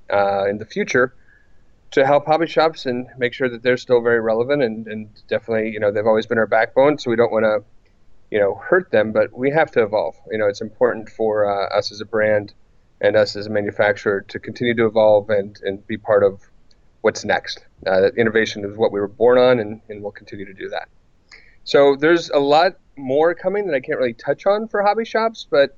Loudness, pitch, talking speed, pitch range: -19 LUFS, 115 Hz, 230 wpm, 105-145 Hz